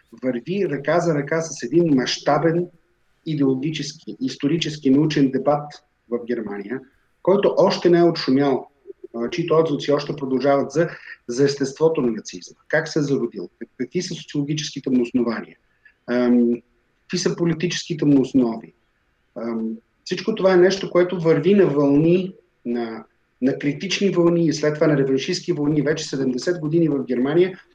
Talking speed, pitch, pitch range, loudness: 140 wpm, 145 Hz, 130-170 Hz, -21 LUFS